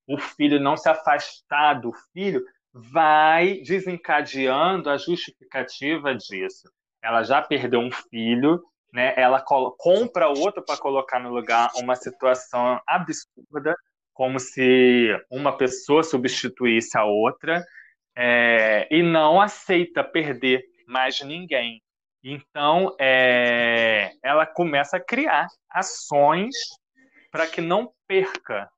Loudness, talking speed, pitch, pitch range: -21 LUFS, 115 wpm, 145 Hz, 125-175 Hz